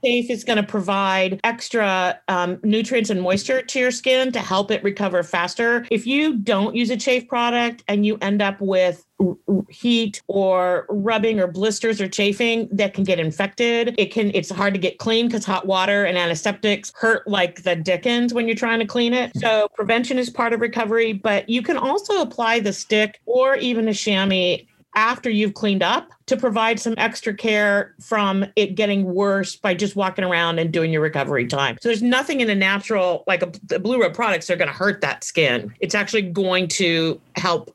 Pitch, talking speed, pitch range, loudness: 210 Hz, 200 wpm, 190-230 Hz, -20 LUFS